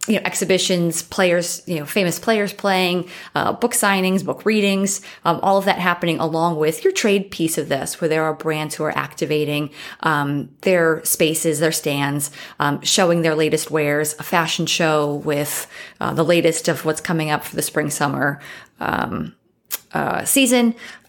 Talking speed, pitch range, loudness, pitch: 170 wpm, 155-185 Hz, -19 LUFS, 165 Hz